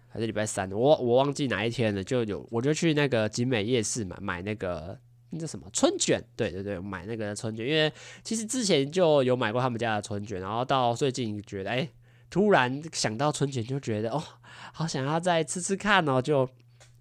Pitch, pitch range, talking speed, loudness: 125 Hz, 110-150 Hz, 305 characters per minute, -28 LUFS